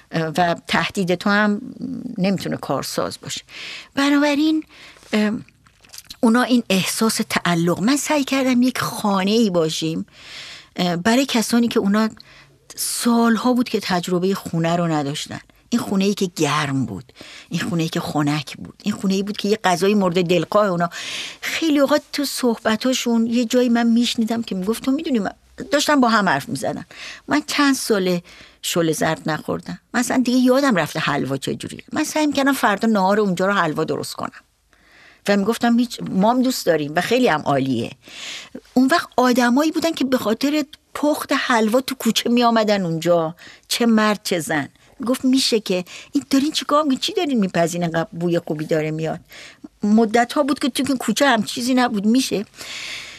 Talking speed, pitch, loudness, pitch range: 160 wpm, 225 Hz, -19 LUFS, 180-255 Hz